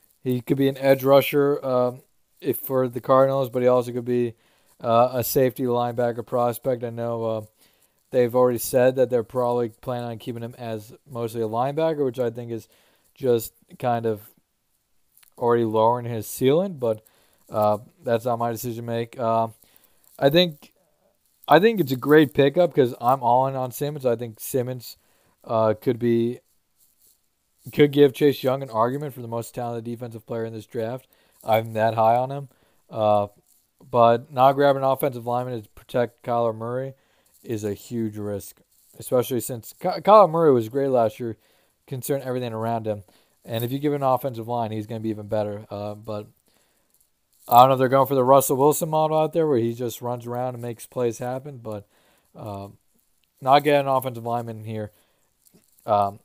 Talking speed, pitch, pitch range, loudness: 185 wpm, 120 Hz, 115-135 Hz, -22 LUFS